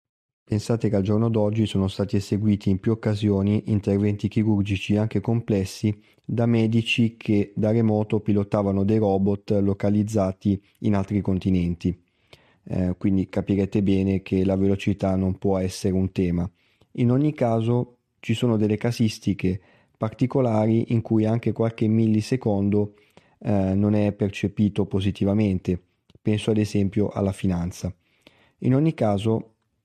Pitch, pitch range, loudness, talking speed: 105 Hz, 100-110 Hz, -23 LUFS, 130 wpm